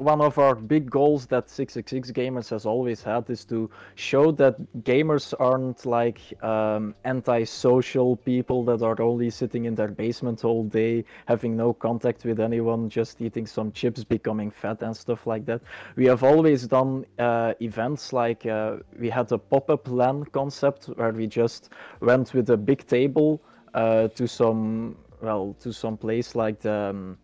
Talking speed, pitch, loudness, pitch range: 165 wpm, 120 Hz, -24 LUFS, 115-130 Hz